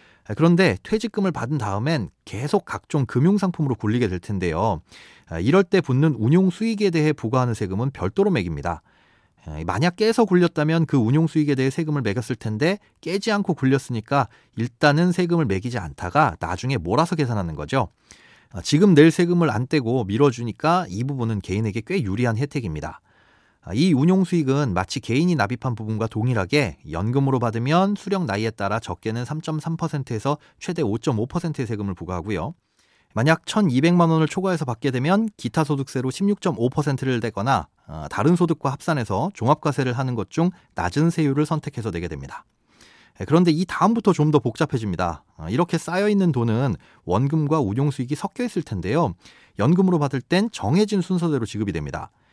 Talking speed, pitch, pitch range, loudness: 355 characters per minute, 140 Hz, 115-170 Hz, -22 LUFS